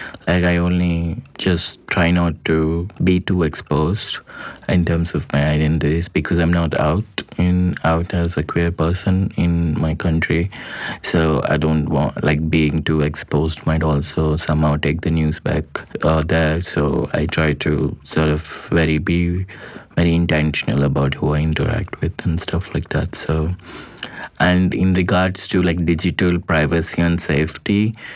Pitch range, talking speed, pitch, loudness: 75-85 Hz, 160 wpm, 80 Hz, -18 LUFS